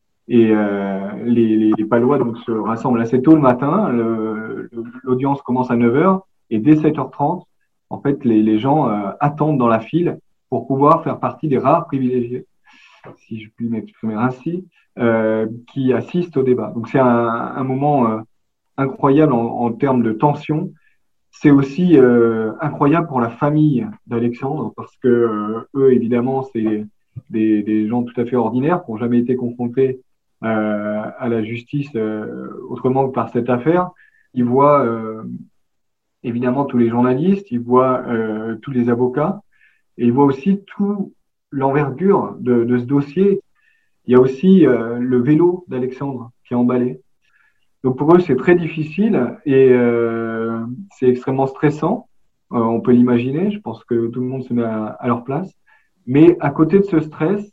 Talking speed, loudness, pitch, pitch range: 170 wpm, -17 LUFS, 125 Hz, 115-145 Hz